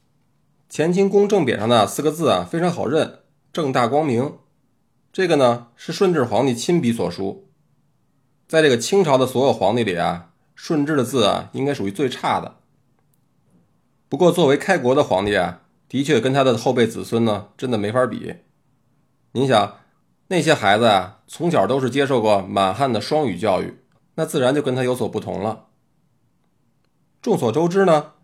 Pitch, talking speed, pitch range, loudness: 135 Hz, 250 characters per minute, 115-155 Hz, -19 LUFS